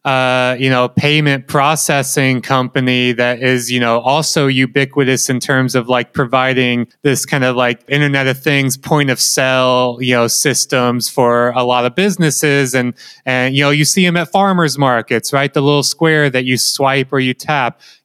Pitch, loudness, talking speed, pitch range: 130 Hz, -13 LUFS, 185 wpm, 125-145 Hz